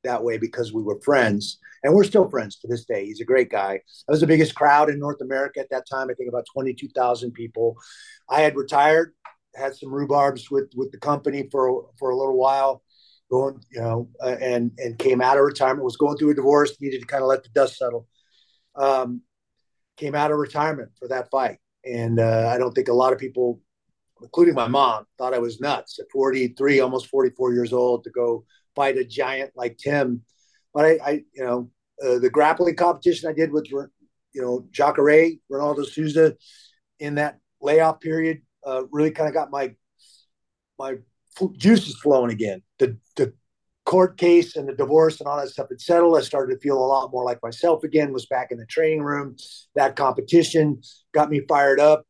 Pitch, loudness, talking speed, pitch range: 135 Hz, -22 LUFS, 200 wpm, 125-150 Hz